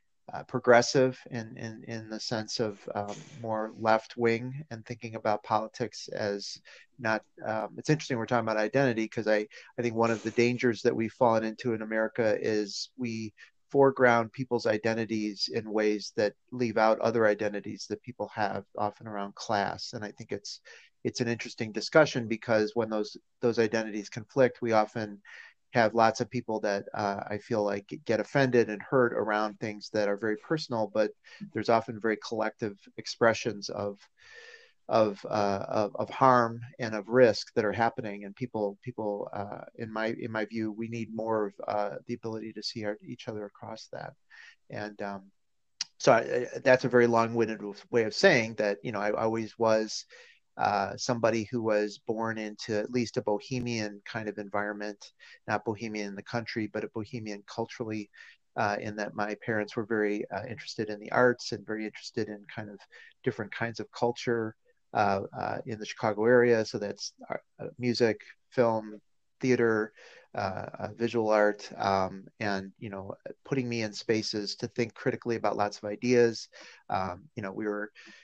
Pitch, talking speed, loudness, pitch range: 110 Hz, 175 wpm, -30 LUFS, 105-120 Hz